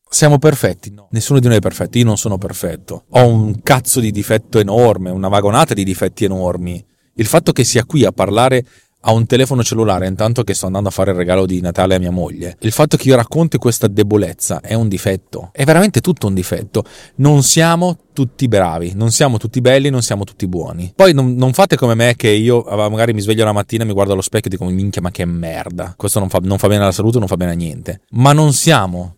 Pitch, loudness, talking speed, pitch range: 110 Hz, -14 LUFS, 230 wpm, 95-125 Hz